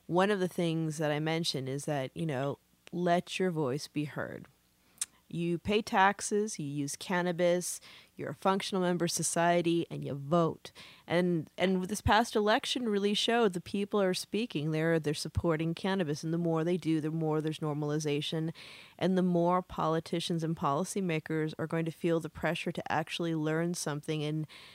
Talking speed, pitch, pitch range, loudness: 175 wpm, 165 Hz, 155-180 Hz, -32 LUFS